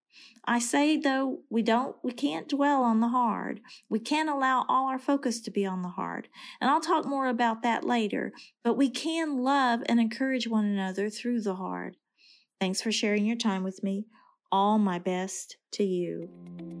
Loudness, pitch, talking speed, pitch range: -28 LUFS, 235 Hz, 185 wpm, 200-265 Hz